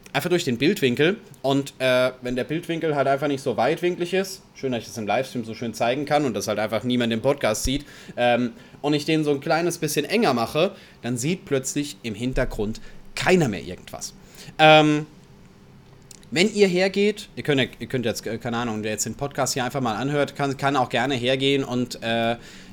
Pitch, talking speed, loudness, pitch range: 135 Hz, 205 wpm, -23 LUFS, 120-155 Hz